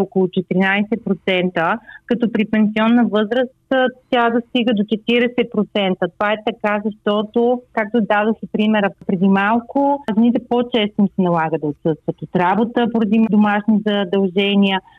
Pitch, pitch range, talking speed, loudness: 215 Hz, 195-235 Hz, 120 wpm, -17 LUFS